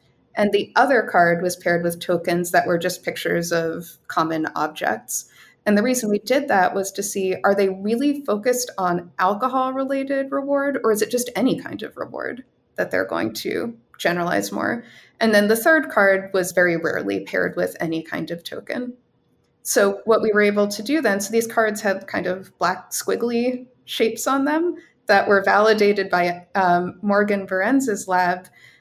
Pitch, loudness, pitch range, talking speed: 205 Hz, -21 LUFS, 180-240 Hz, 180 wpm